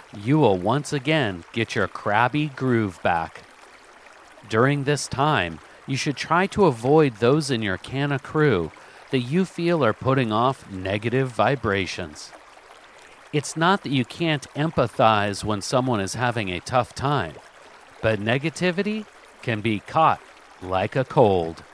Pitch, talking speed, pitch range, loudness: 130 Hz, 145 wpm, 110-150 Hz, -23 LUFS